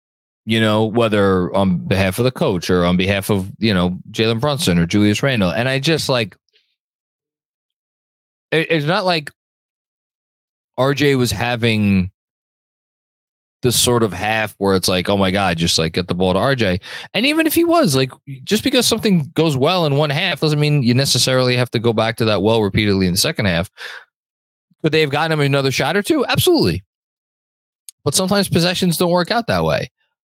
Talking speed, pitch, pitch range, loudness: 185 wpm, 125 Hz, 100-155 Hz, -16 LUFS